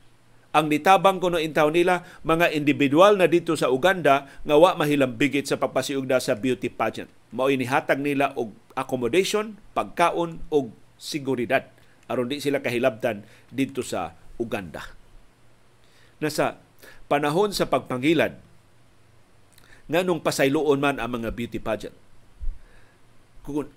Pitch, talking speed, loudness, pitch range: 140 Hz, 115 wpm, -23 LUFS, 120-160 Hz